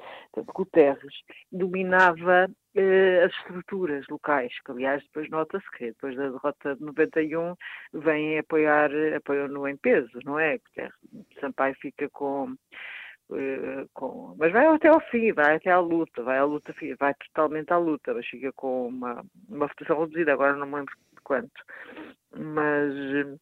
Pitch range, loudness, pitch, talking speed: 140-175 Hz, -25 LUFS, 150 Hz, 155 wpm